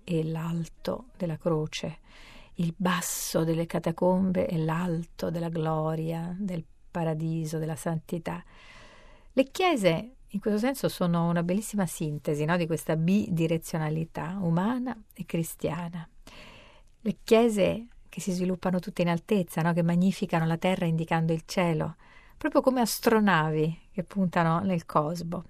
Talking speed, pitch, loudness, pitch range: 130 wpm, 175 Hz, -28 LUFS, 165-190 Hz